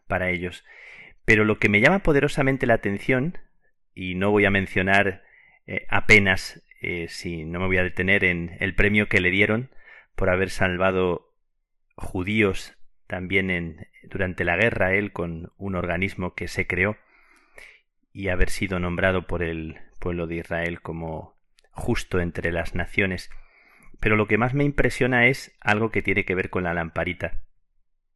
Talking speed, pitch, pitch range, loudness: 160 wpm, 95 Hz, 90-105 Hz, -23 LUFS